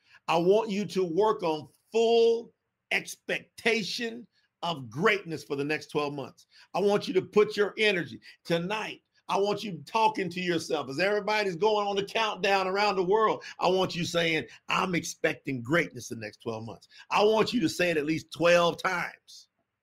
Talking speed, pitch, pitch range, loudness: 180 wpm, 185 Hz, 160-210 Hz, -28 LUFS